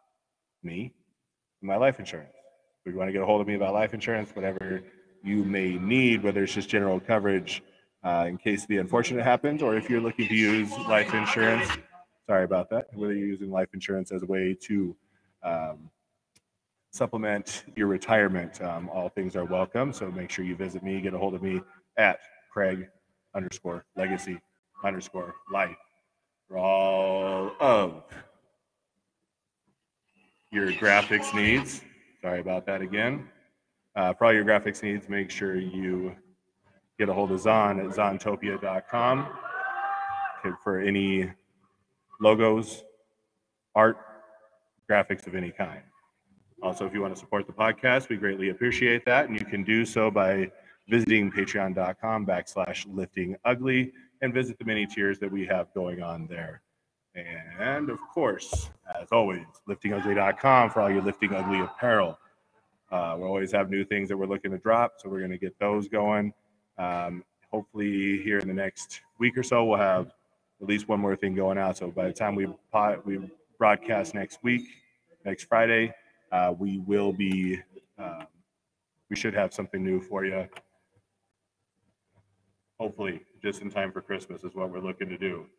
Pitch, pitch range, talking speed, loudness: 100 Hz, 95-110 Hz, 160 wpm, -27 LUFS